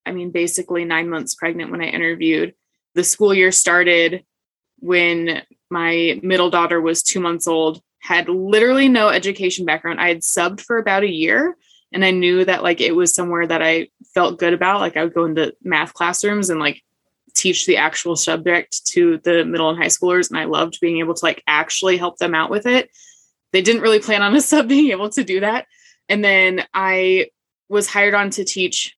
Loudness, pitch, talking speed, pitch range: -17 LUFS, 180 Hz, 205 wpm, 170-205 Hz